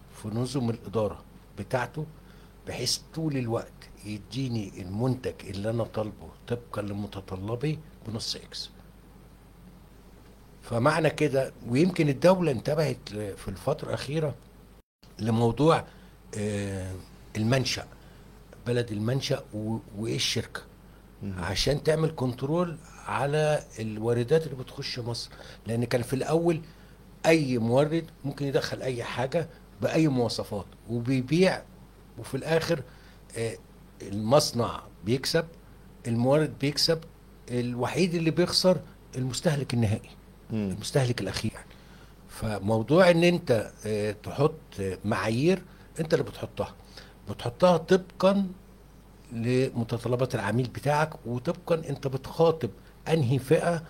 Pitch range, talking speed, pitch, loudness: 110-155 Hz, 90 wpm, 130 Hz, -28 LUFS